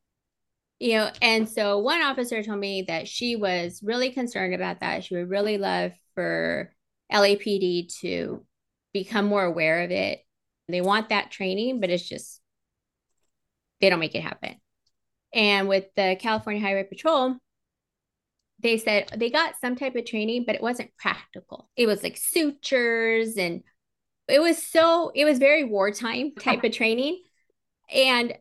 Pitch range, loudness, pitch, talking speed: 195-250 Hz, -24 LUFS, 220 Hz, 155 wpm